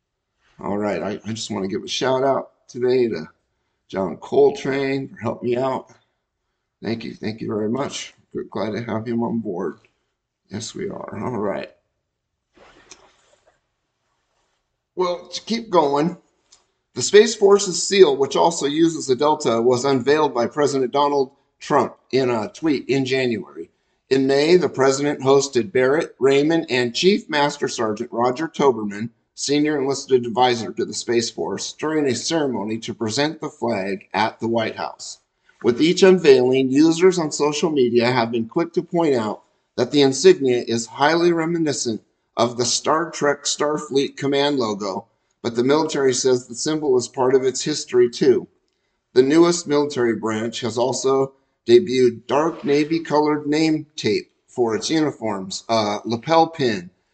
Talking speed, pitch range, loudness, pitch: 155 wpm, 120-165 Hz, -20 LUFS, 140 Hz